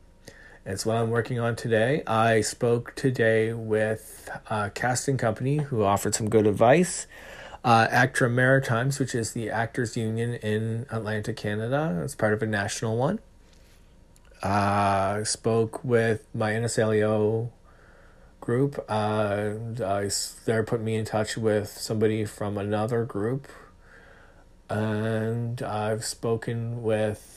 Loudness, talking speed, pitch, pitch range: -26 LUFS, 125 wpm, 110 Hz, 105-120 Hz